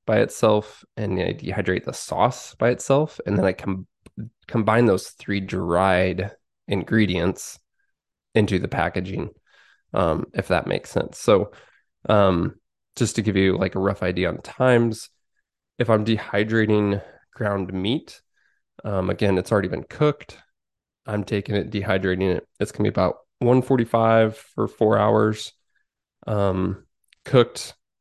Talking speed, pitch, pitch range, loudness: 145 wpm, 105 Hz, 95-115 Hz, -22 LUFS